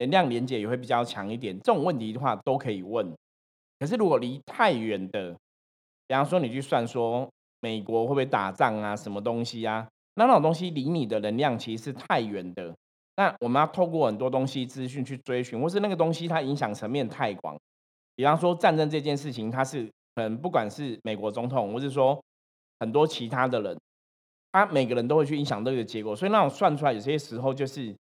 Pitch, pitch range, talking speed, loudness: 125 Hz, 110-140 Hz, 320 characters per minute, -27 LUFS